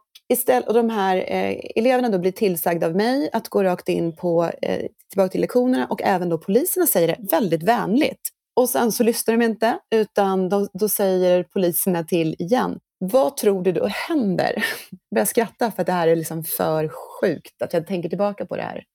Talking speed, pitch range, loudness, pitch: 195 wpm, 180-235 Hz, -21 LUFS, 195 Hz